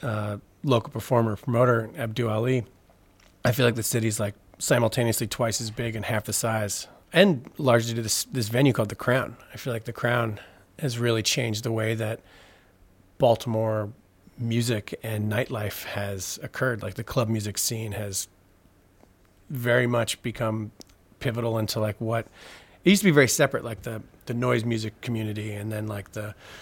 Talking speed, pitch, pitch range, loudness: 170 wpm, 110 Hz, 105-120 Hz, -26 LUFS